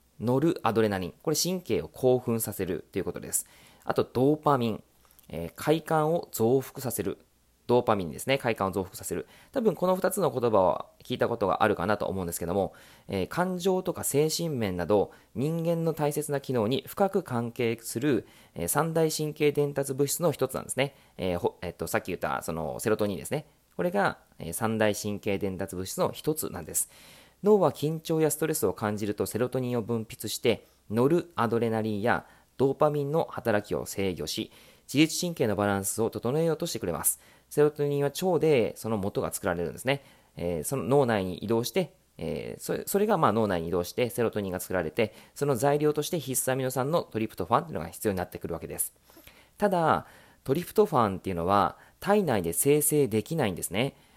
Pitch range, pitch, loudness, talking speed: 100-150 Hz, 125 Hz, -28 LUFS, 395 characters per minute